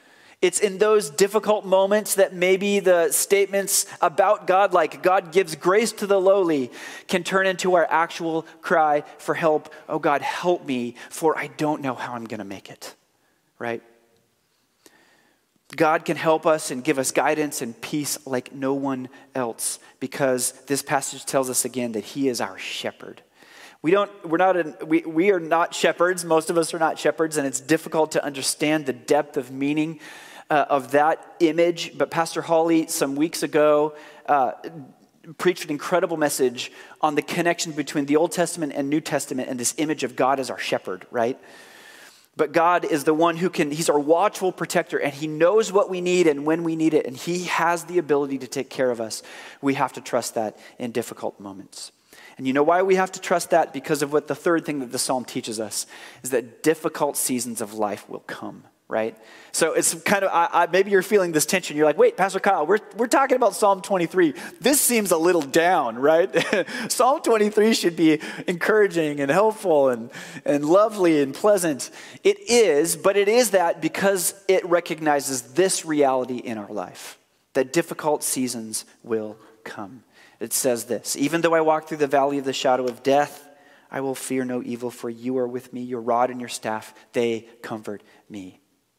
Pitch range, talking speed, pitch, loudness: 130-180 Hz, 195 wpm, 155 Hz, -22 LUFS